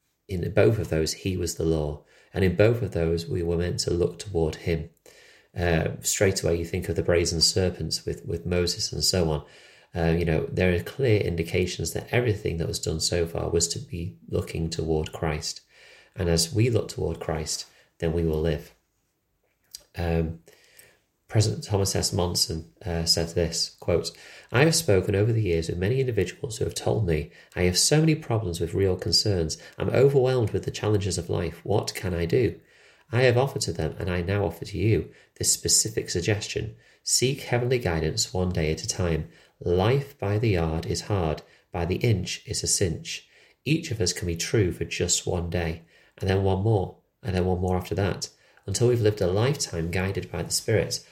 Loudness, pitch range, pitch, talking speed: -25 LUFS, 85-105 Hz, 90 Hz, 200 wpm